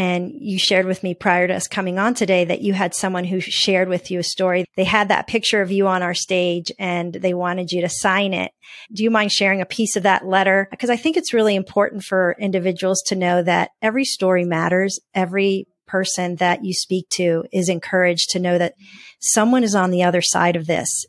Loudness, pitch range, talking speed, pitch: -19 LUFS, 180-200 Hz, 225 wpm, 185 Hz